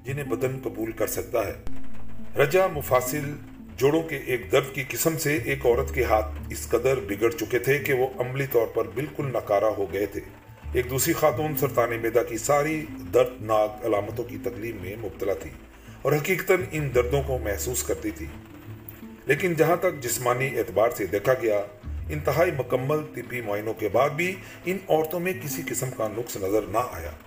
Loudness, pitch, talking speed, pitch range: -26 LUFS, 125 Hz, 180 wpm, 110-145 Hz